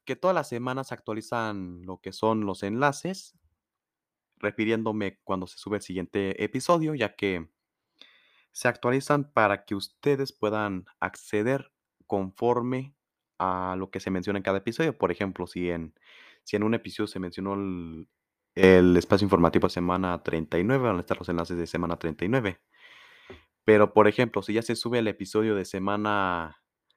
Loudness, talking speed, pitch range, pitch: -27 LUFS, 160 wpm, 90-115 Hz, 100 Hz